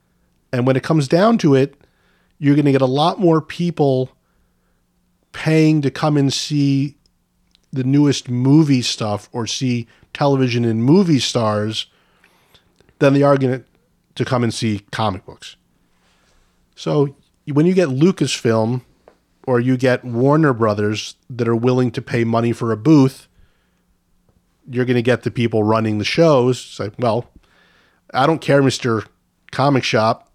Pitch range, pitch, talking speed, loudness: 115-145 Hz, 130 Hz, 150 wpm, -17 LUFS